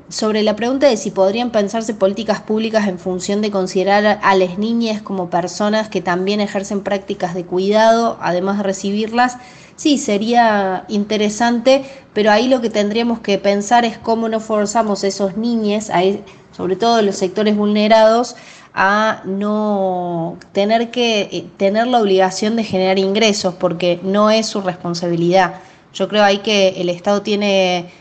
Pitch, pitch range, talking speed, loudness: 205 Hz, 190-220 Hz, 150 wpm, -16 LUFS